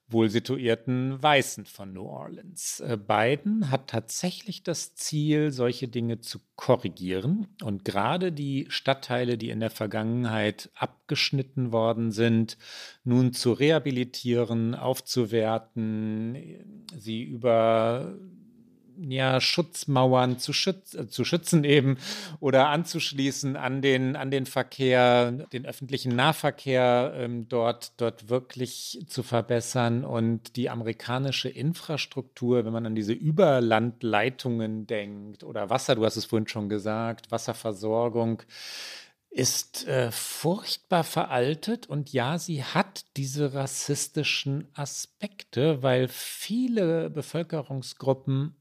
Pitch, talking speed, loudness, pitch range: 130 Hz, 110 wpm, -27 LUFS, 115-145 Hz